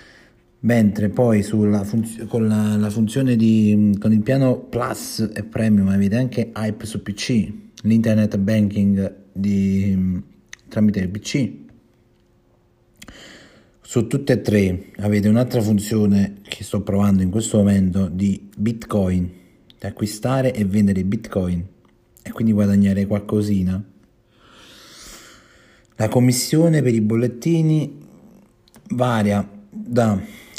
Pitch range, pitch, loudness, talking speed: 100-115 Hz, 105 Hz, -19 LUFS, 110 wpm